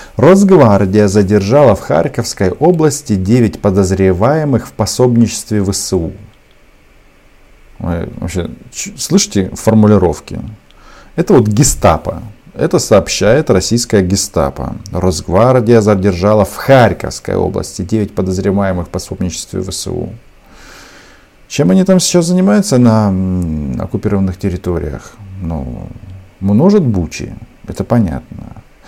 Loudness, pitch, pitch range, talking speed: -12 LUFS, 105 Hz, 95-120 Hz, 85 wpm